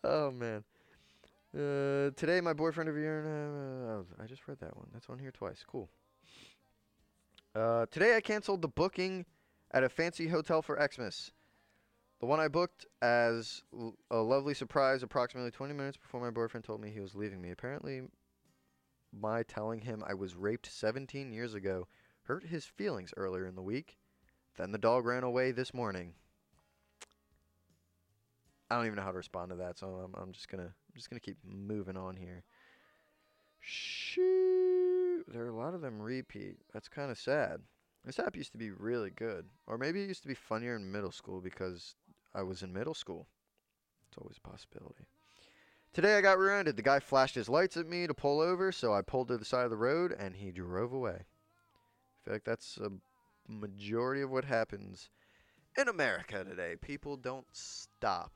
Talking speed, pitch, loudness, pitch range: 185 wpm, 120 Hz, -36 LUFS, 95-140 Hz